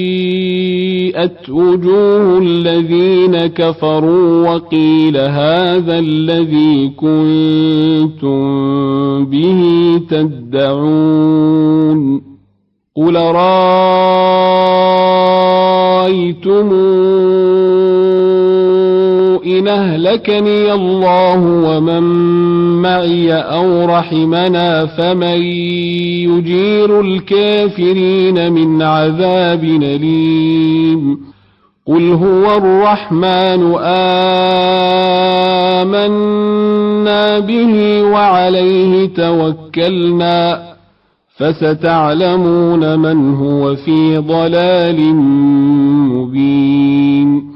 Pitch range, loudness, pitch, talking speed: 155-185 Hz, -11 LUFS, 175 Hz, 45 wpm